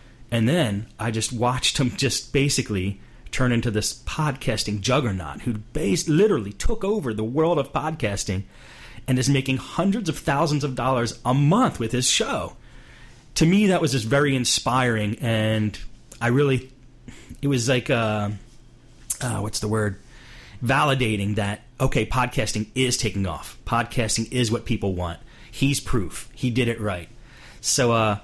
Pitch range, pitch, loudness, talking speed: 110-130 Hz, 120 Hz, -23 LUFS, 155 wpm